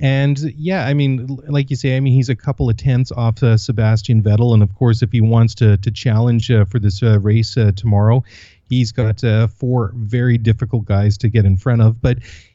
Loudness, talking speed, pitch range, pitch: -15 LUFS, 225 wpm, 110-130 Hz, 115 Hz